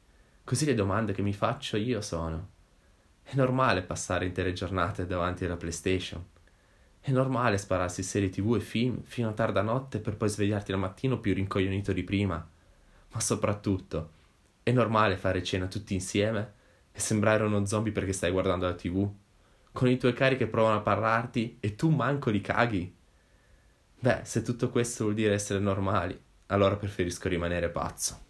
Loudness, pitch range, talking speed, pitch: -29 LUFS, 90-115 Hz, 165 wpm, 100 Hz